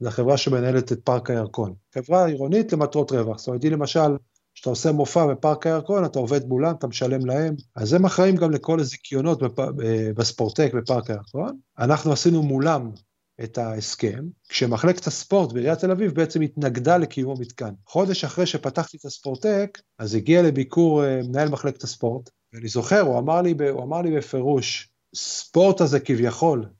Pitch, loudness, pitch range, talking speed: 140 Hz, -22 LUFS, 125-165 Hz, 160 wpm